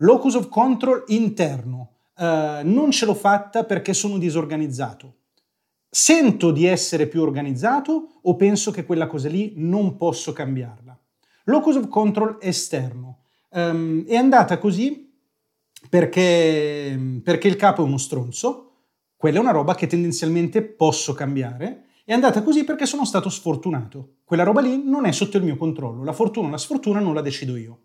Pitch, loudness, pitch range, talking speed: 175 Hz, -20 LUFS, 150-220 Hz, 160 wpm